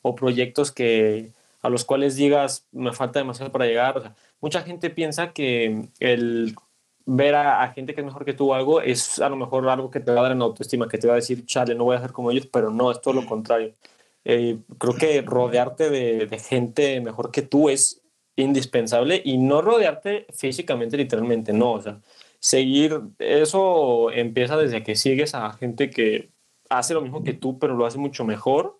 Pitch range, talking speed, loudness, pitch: 120-145 Hz, 205 wpm, -22 LUFS, 130 Hz